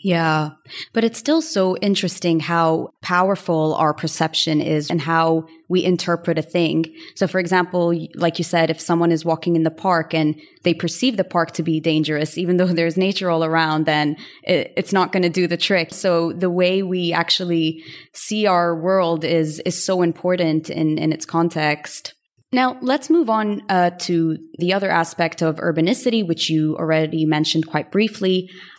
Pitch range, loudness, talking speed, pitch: 160-185 Hz, -19 LUFS, 180 wpm, 170 Hz